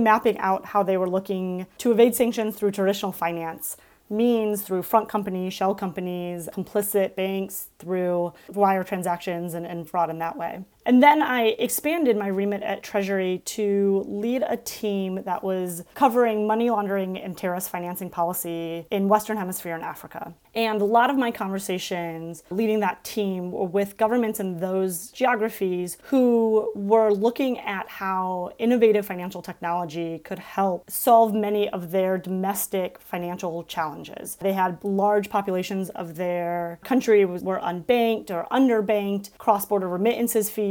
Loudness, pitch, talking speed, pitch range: -24 LUFS, 195 Hz, 150 wpm, 180-215 Hz